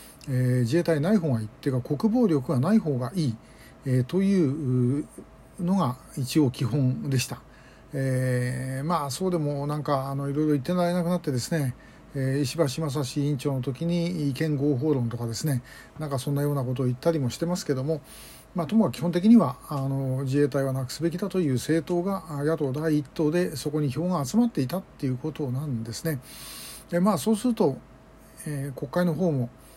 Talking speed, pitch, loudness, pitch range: 365 characters per minute, 145 Hz, -26 LUFS, 130-170 Hz